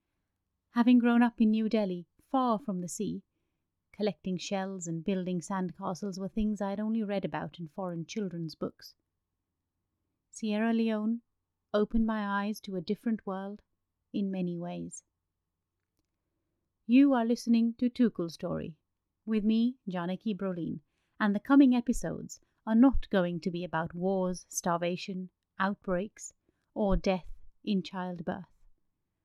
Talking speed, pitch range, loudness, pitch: 135 wpm, 165-215 Hz, -31 LUFS, 190 Hz